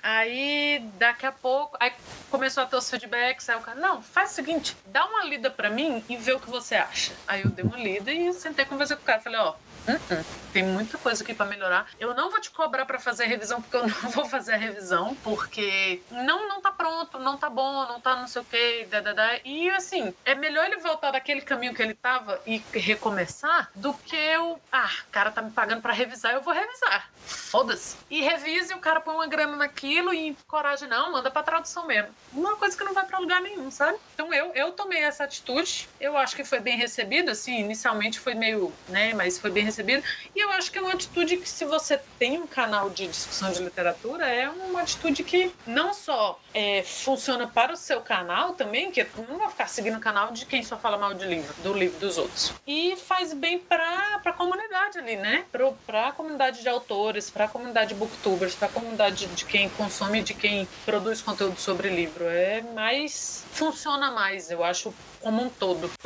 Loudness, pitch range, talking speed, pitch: -26 LUFS, 220-320 Hz, 220 wpm, 255 Hz